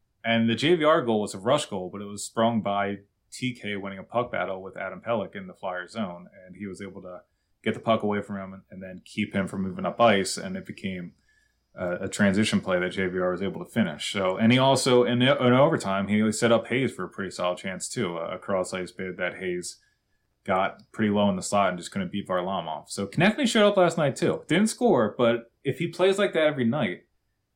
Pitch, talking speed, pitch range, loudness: 105 Hz, 235 wpm, 95-130 Hz, -26 LUFS